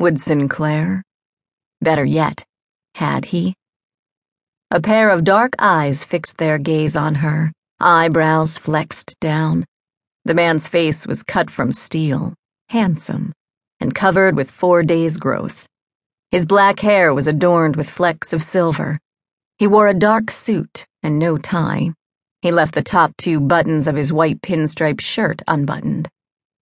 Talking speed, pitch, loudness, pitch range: 140 wpm, 165 Hz, -17 LUFS, 155-180 Hz